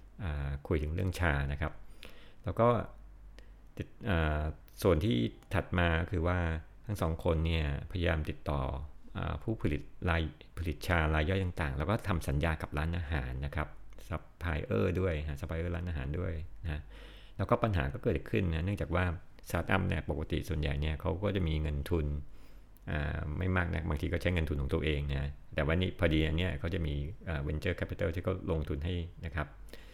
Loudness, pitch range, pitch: -34 LUFS, 75-90 Hz, 80 Hz